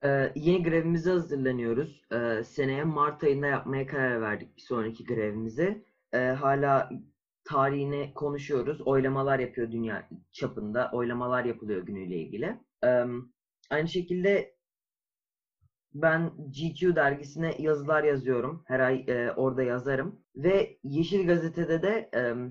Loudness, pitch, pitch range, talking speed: -29 LUFS, 140 Hz, 125-160 Hz, 115 wpm